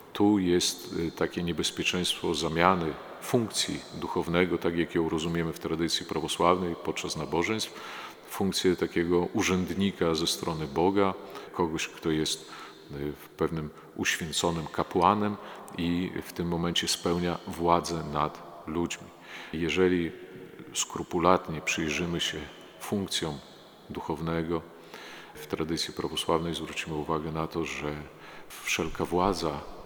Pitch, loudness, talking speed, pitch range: 85 Hz, -29 LUFS, 105 wpm, 80-90 Hz